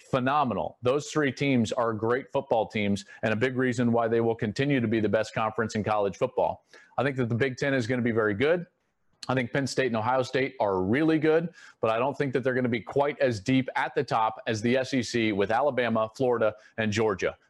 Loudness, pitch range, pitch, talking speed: -27 LUFS, 110-130 Hz, 125 Hz, 235 wpm